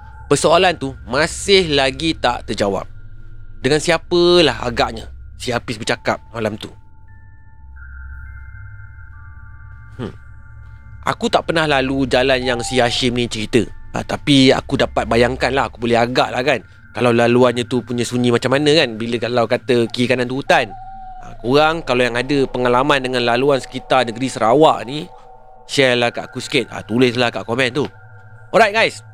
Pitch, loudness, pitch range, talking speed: 120 Hz, -16 LUFS, 110-130 Hz, 155 wpm